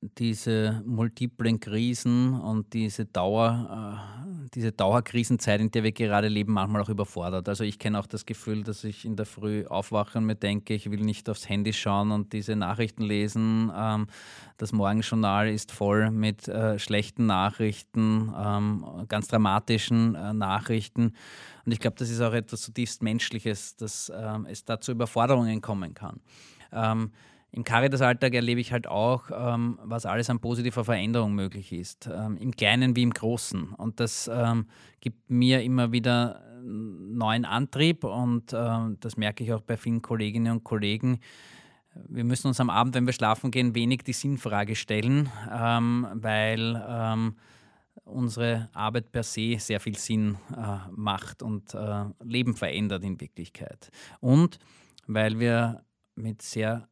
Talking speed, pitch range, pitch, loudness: 160 wpm, 105-120 Hz, 110 Hz, -28 LUFS